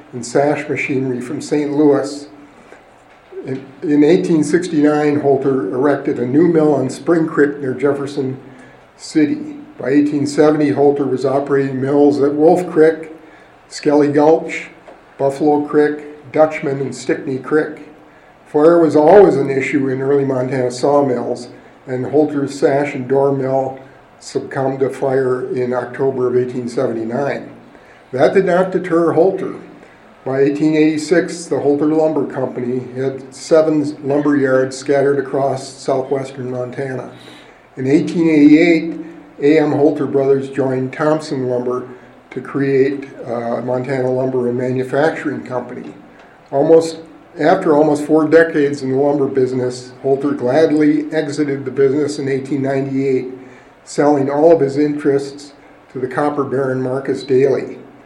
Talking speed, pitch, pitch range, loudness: 125 wpm, 140 Hz, 130-150 Hz, -15 LUFS